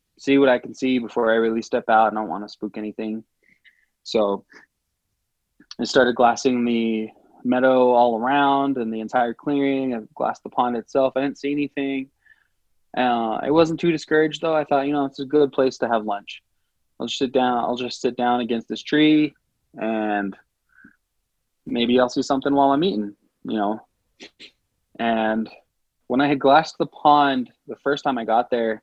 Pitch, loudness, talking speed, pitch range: 125 Hz, -21 LUFS, 185 wpm, 110-140 Hz